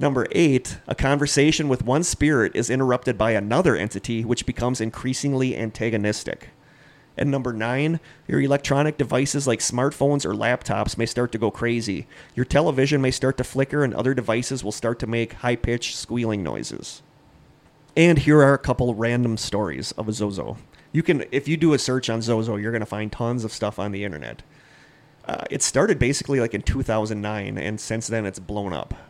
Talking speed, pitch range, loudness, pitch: 185 wpm, 110-140 Hz, -23 LUFS, 120 Hz